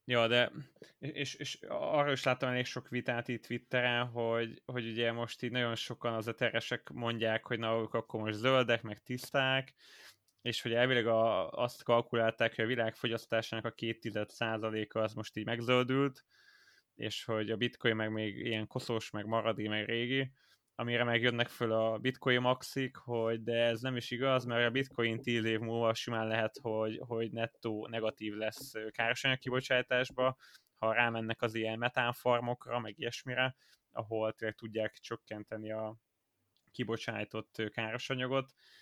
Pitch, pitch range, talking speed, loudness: 115 Hz, 110-125 Hz, 155 wpm, -34 LUFS